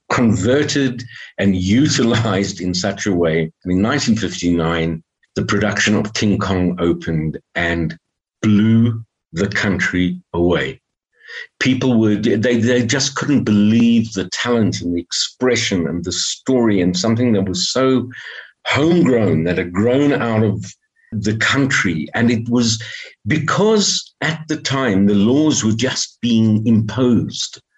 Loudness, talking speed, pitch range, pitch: -17 LUFS, 135 wpm, 95-125 Hz, 110 Hz